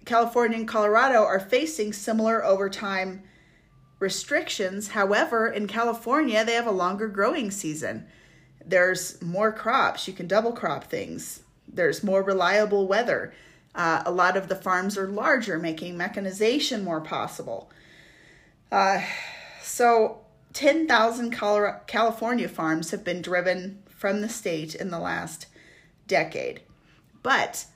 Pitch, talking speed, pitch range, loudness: 205 Hz, 125 wpm, 185-230 Hz, -25 LUFS